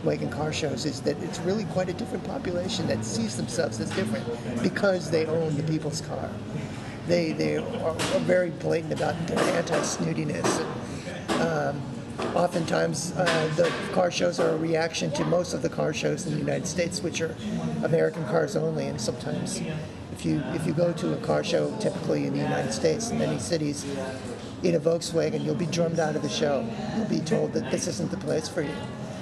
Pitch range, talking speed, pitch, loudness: 145-175 Hz, 190 wpm, 165 Hz, -27 LUFS